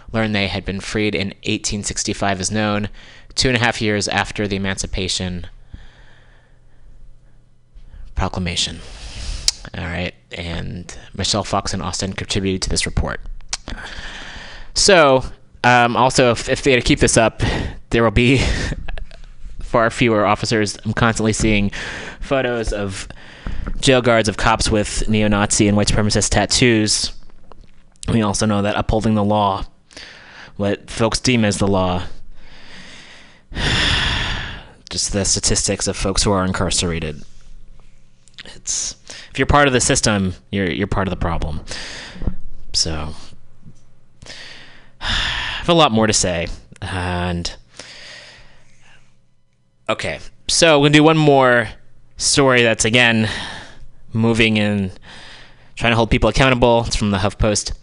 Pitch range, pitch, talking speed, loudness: 90-115 Hz, 100 Hz, 130 wpm, -17 LUFS